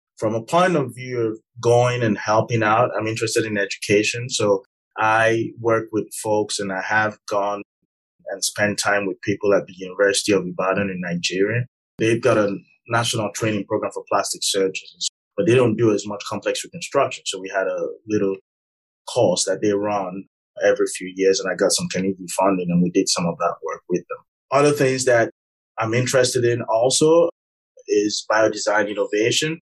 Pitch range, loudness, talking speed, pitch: 100-125 Hz, -20 LUFS, 180 wpm, 110 Hz